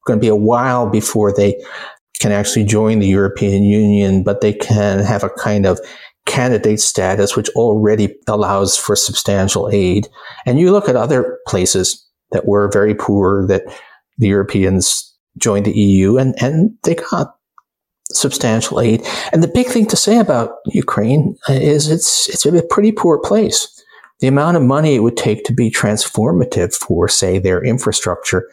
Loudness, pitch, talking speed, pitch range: -14 LUFS, 105 Hz, 165 wpm, 100-130 Hz